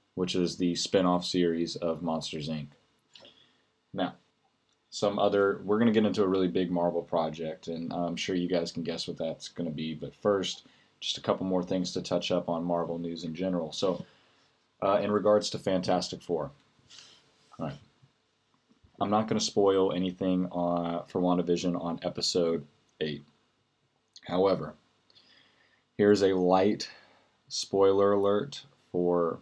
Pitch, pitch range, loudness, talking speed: 90 Hz, 85-100 Hz, -29 LUFS, 155 wpm